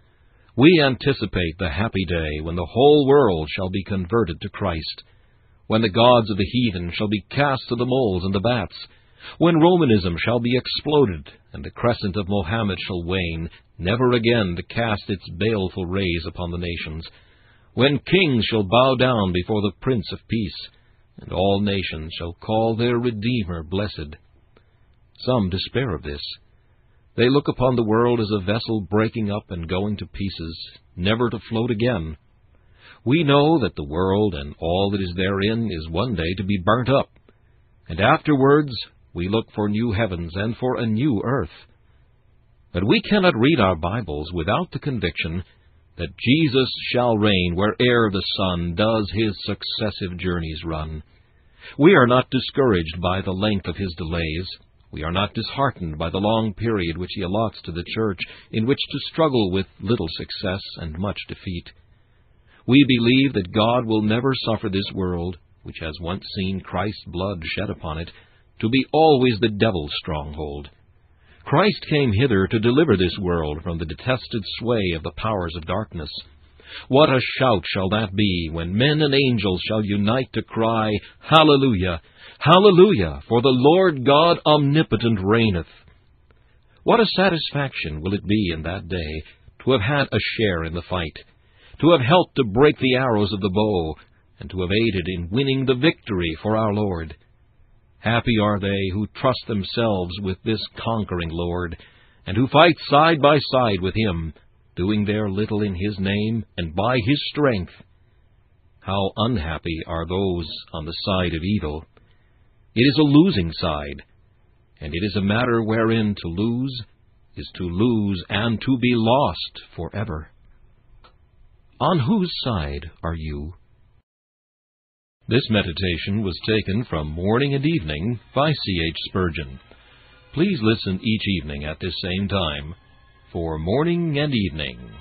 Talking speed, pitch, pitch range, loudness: 160 wpm, 105 Hz, 90-120 Hz, -21 LUFS